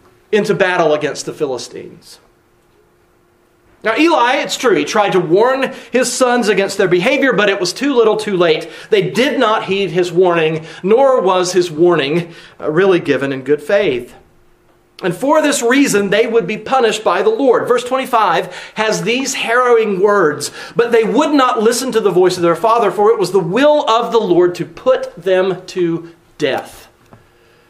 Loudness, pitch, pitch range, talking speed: -14 LUFS, 210 Hz, 180-250 Hz, 175 wpm